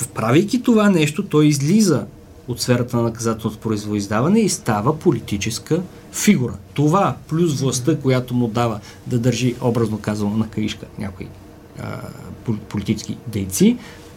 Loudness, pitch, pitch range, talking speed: -19 LUFS, 120 Hz, 110-155 Hz, 125 wpm